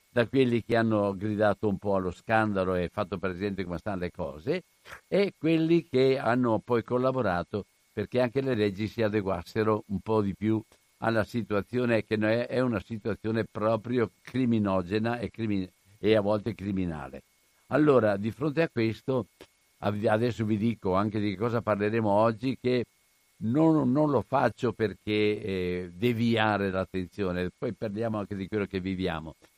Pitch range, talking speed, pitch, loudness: 100-120 Hz, 145 wpm, 110 Hz, -28 LUFS